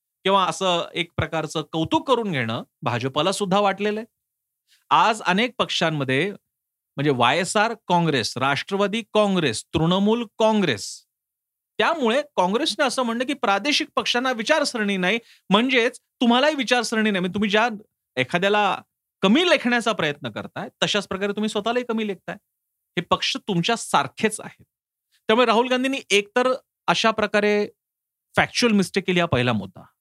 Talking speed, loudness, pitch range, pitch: 135 wpm, -22 LUFS, 175-235 Hz, 205 Hz